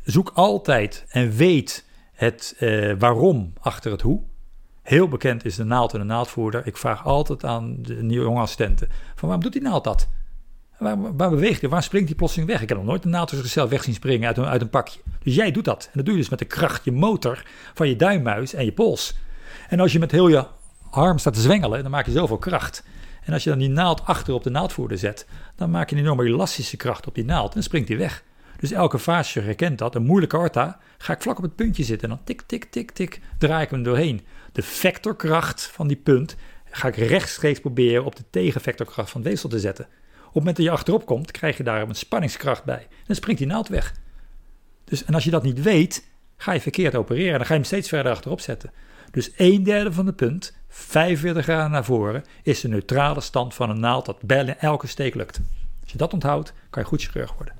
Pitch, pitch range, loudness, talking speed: 140 Hz, 115-165 Hz, -22 LUFS, 235 wpm